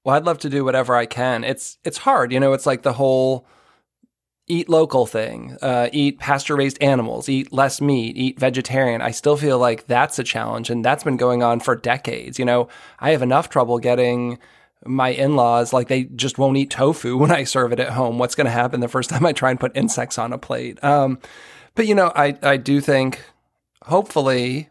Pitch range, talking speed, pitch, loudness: 125-140 Hz, 220 wpm, 130 Hz, -19 LUFS